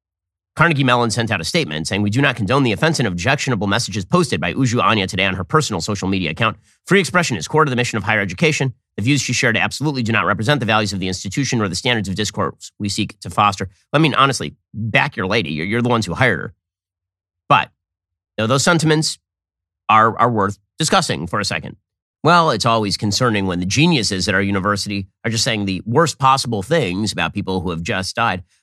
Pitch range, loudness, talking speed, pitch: 95-130 Hz, -17 LUFS, 225 wpm, 110 Hz